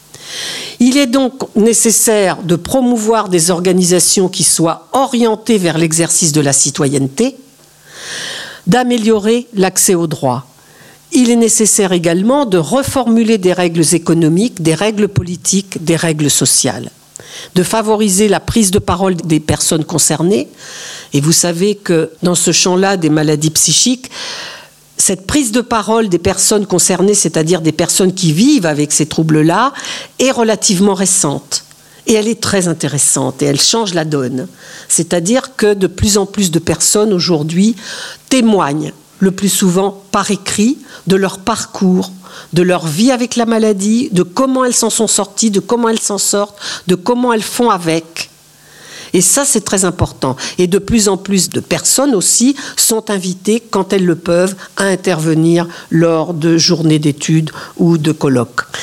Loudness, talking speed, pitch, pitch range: -12 LUFS, 155 wpm, 190 Hz, 165-220 Hz